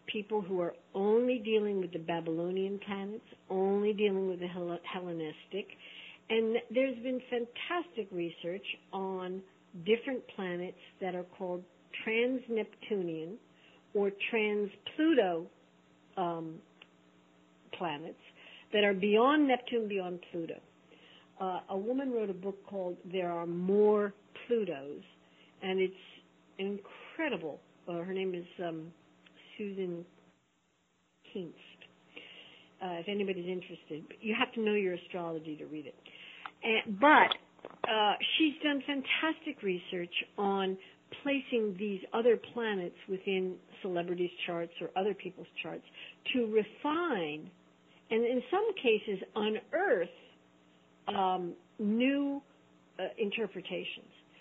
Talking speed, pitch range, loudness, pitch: 110 wpm, 170-220 Hz, -34 LUFS, 190 Hz